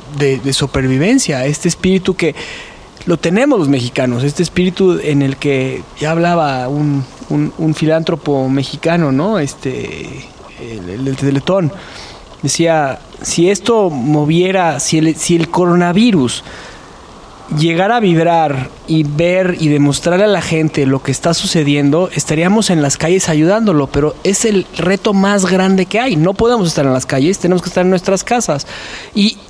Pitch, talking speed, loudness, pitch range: 160 Hz, 155 wpm, -13 LUFS, 145-185 Hz